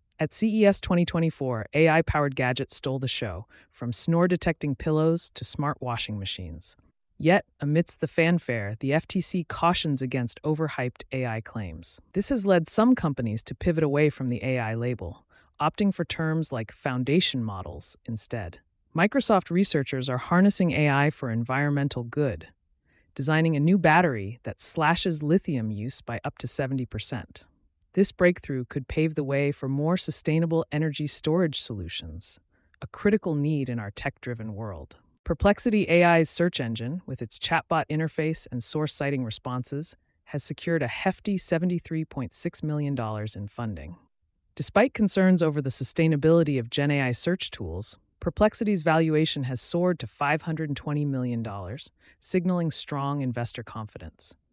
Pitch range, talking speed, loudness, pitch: 115-165 Hz, 140 wpm, -26 LUFS, 145 Hz